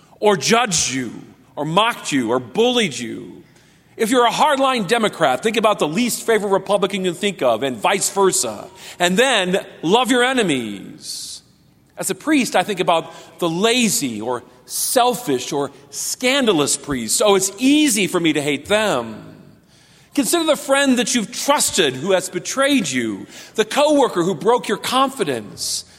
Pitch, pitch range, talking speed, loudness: 205 Hz, 165-240 Hz, 160 wpm, -18 LUFS